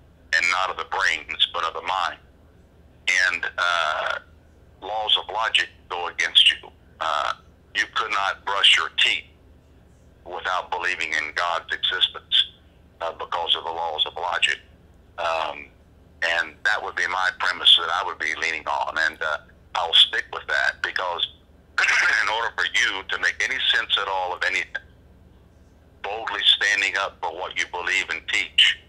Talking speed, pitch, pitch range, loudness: 160 wpm, 85 Hz, 80-90 Hz, -21 LUFS